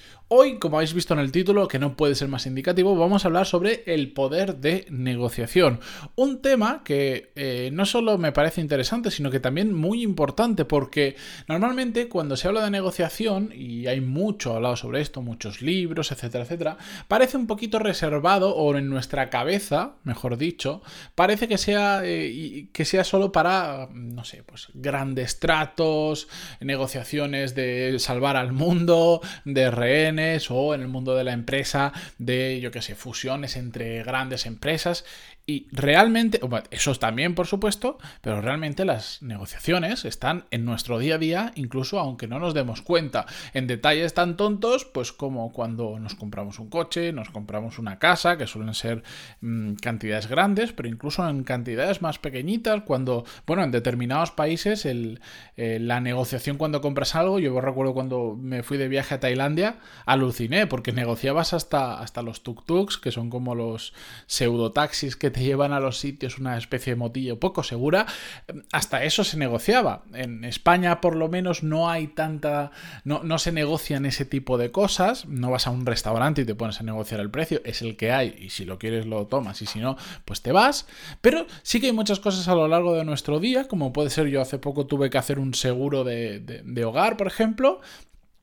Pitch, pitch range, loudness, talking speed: 140 Hz, 125-175 Hz, -24 LUFS, 185 wpm